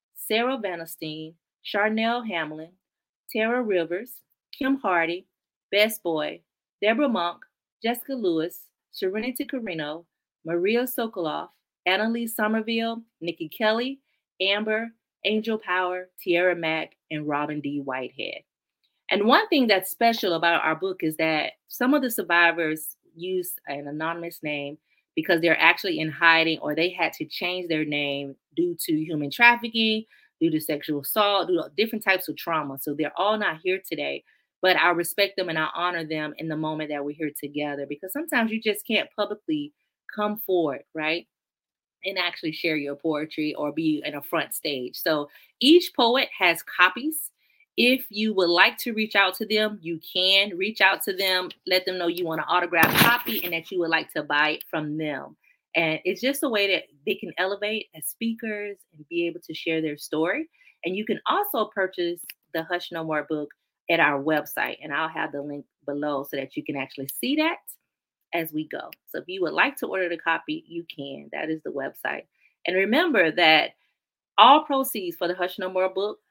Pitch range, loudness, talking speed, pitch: 155-220 Hz, -24 LUFS, 180 wpm, 180 Hz